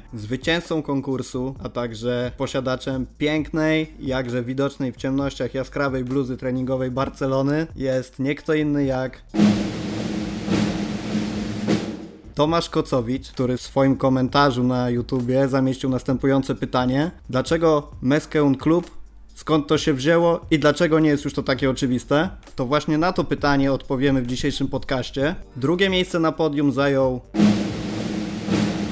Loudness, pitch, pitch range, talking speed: -22 LUFS, 135 Hz, 125-145 Hz, 120 wpm